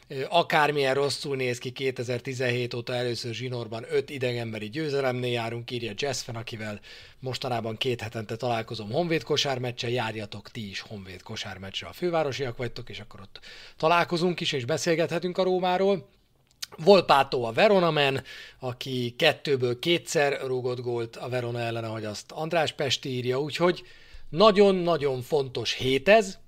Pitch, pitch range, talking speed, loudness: 130 Hz, 120-155 Hz, 135 wpm, -26 LUFS